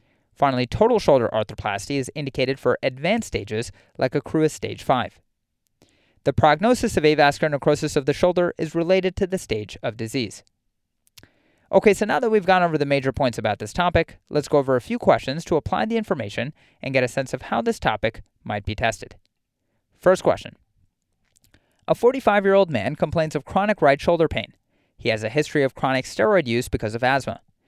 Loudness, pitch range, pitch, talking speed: -22 LUFS, 115-170 Hz, 140 Hz, 185 wpm